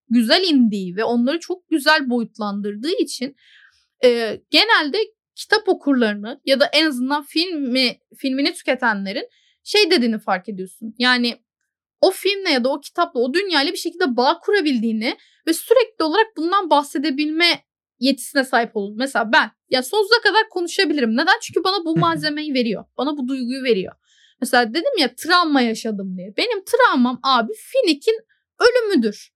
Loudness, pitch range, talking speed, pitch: -19 LUFS, 240-360 Hz, 145 wpm, 285 Hz